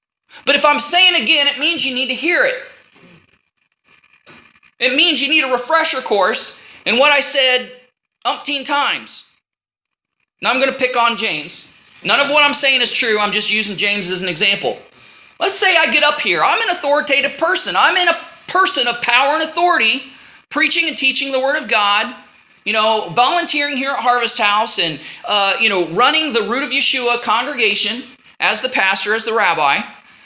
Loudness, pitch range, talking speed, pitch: -13 LUFS, 225-300 Hz, 185 wpm, 265 Hz